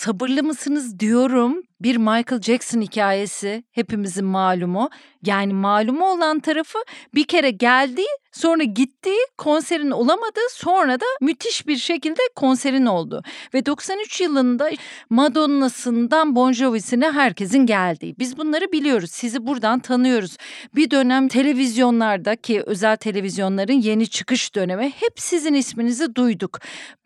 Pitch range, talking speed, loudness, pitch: 225-305 Hz, 120 wpm, -20 LUFS, 255 Hz